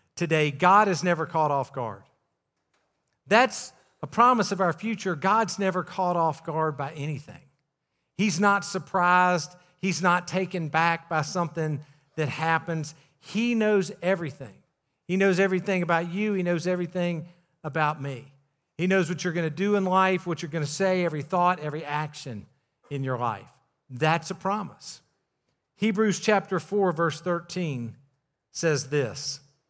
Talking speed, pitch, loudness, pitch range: 150 wpm, 170 Hz, -26 LUFS, 150-190 Hz